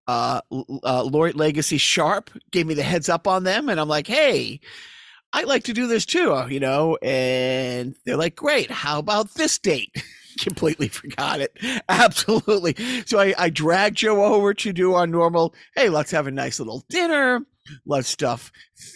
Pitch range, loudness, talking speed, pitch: 150-220 Hz, -21 LUFS, 175 wpm, 175 Hz